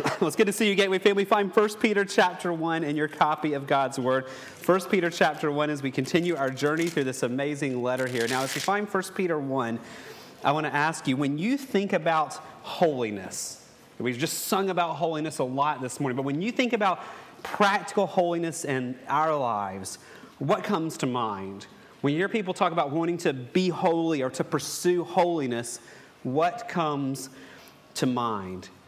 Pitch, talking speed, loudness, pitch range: 155 Hz, 195 wpm, -26 LUFS, 135-185 Hz